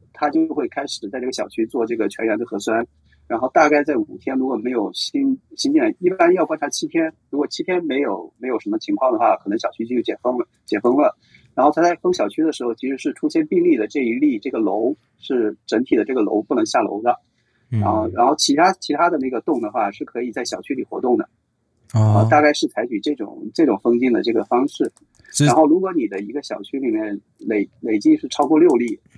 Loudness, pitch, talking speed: -20 LUFS, 310 Hz, 330 characters per minute